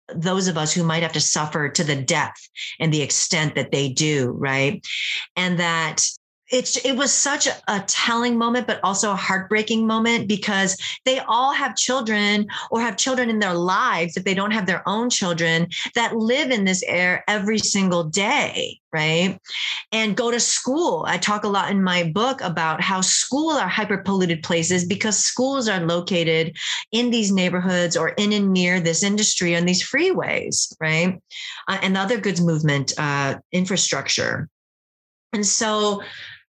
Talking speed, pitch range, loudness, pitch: 170 wpm, 170-225 Hz, -20 LUFS, 195 Hz